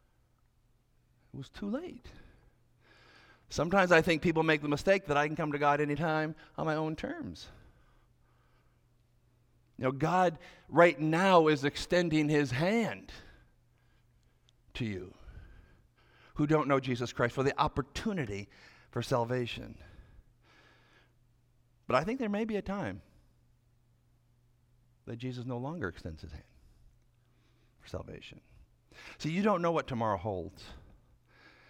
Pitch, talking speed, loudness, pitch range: 125 Hz, 125 wpm, -31 LUFS, 120-155 Hz